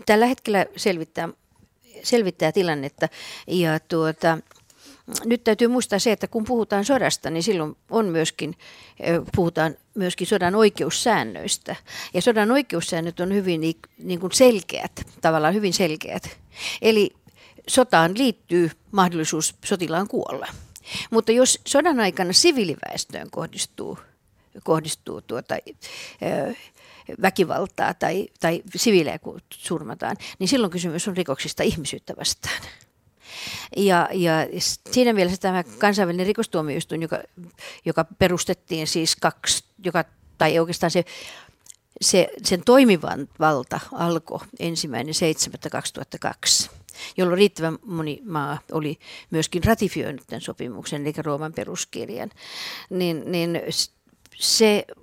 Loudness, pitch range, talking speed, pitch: -22 LUFS, 160-210 Hz, 110 wpm, 180 Hz